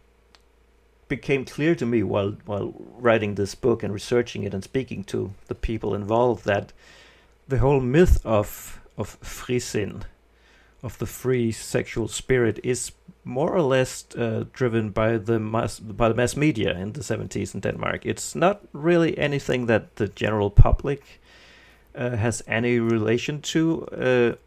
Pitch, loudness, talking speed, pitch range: 115 Hz, -24 LUFS, 155 wpm, 105-130 Hz